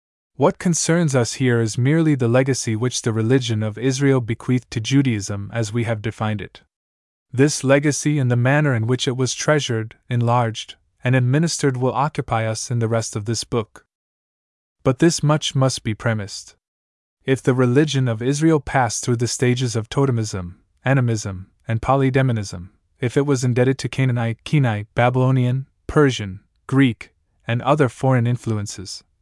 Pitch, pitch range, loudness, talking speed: 125 Hz, 110-135 Hz, -20 LUFS, 160 wpm